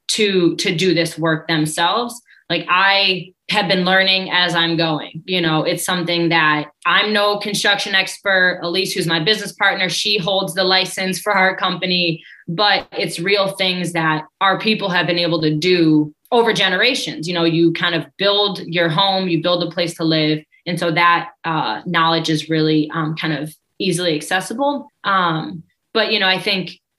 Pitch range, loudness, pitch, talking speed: 165-195 Hz, -17 LUFS, 180 Hz, 180 wpm